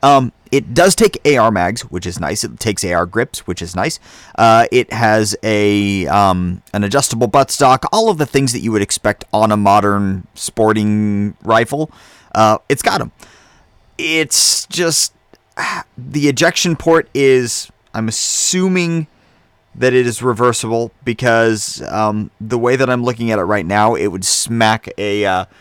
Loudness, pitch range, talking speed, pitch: -14 LUFS, 105-135 Hz, 160 wpm, 115 Hz